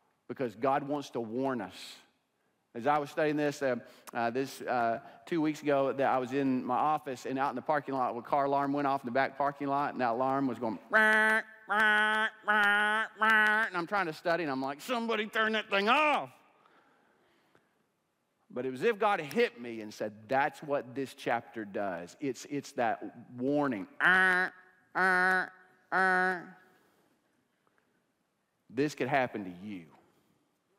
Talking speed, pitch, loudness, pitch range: 175 wpm, 145 Hz, -30 LUFS, 135-190 Hz